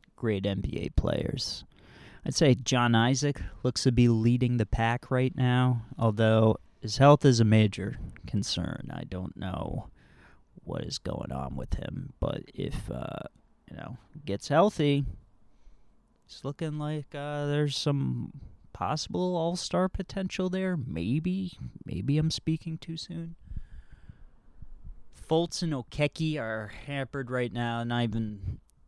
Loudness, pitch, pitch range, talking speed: -29 LUFS, 125 Hz, 110-150 Hz, 135 wpm